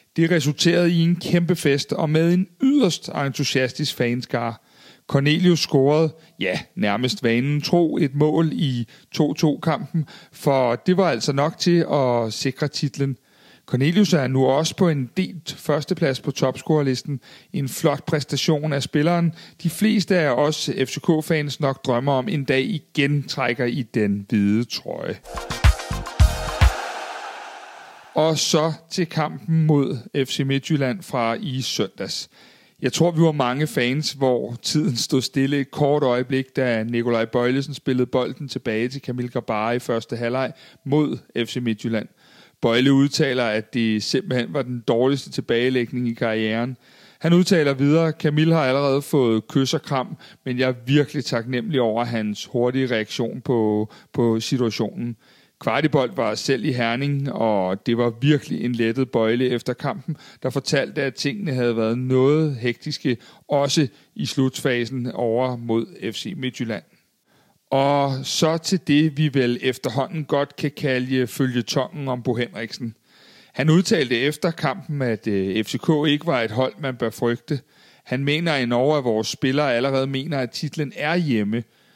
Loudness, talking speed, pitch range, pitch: -22 LUFS, 150 wpm, 125-155 Hz, 135 Hz